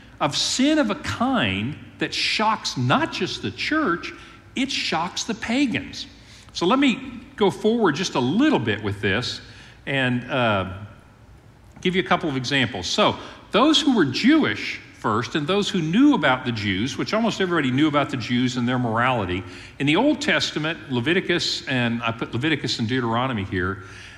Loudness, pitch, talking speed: -22 LUFS, 140 Hz, 170 wpm